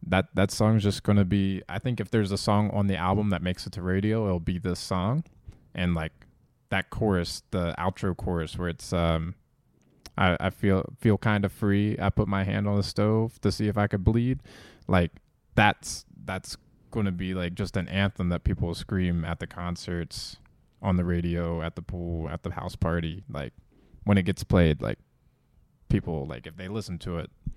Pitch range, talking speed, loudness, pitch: 85-105 Hz, 205 wpm, -28 LUFS, 95 Hz